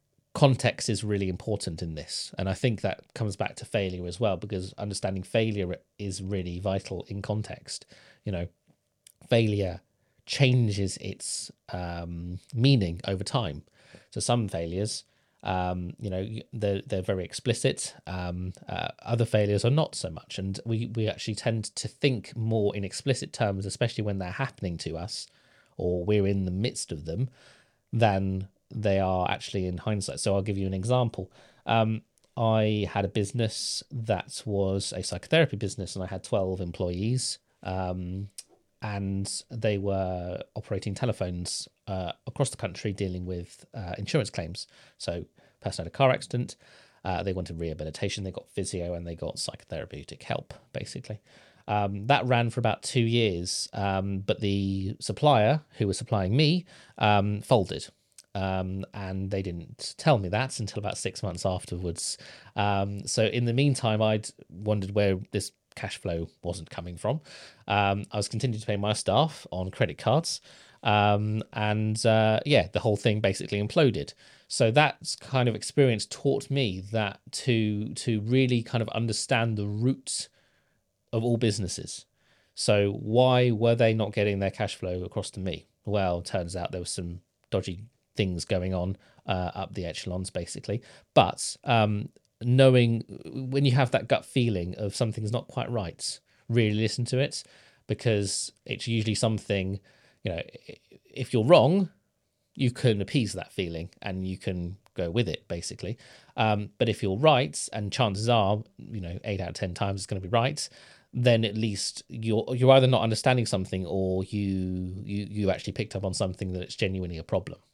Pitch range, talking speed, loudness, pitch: 95-115 Hz, 165 wpm, -28 LUFS, 105 Hz